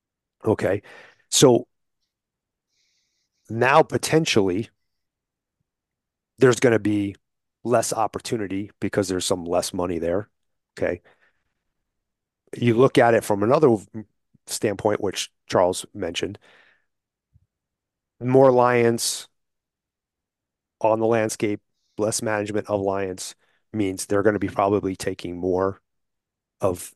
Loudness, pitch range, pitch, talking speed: -22 LUFS, 95-115 Hz, 105 Hz, 100 wpm